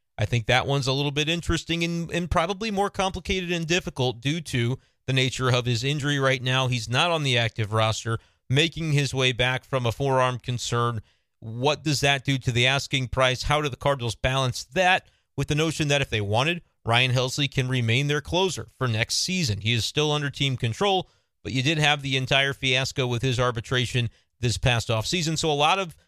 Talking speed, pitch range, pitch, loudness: 210 wpm, 120-150 Hz, 130 Hz, -24 LUFS